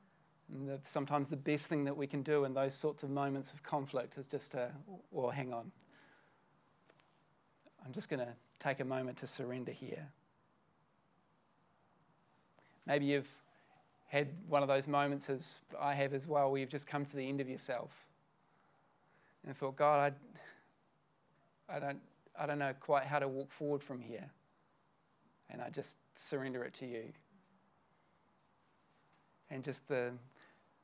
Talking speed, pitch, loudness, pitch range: 155 wpm, 140 Hz, -39 LUFS, 135-145 Hz